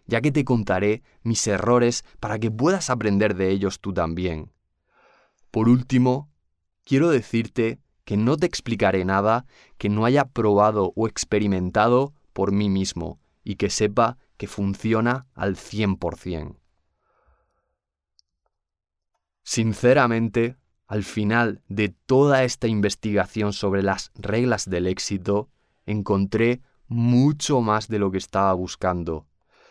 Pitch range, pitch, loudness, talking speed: 95-120 Hz, 105 Hz, -23 LUFS, 120 wpm